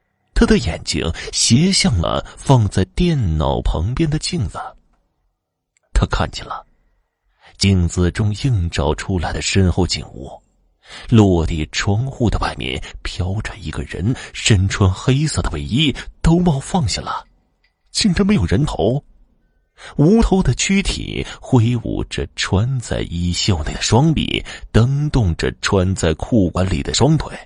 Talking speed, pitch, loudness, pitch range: 195 characters per minute, 100 Hz, -18 LUFS, 90-135 Hz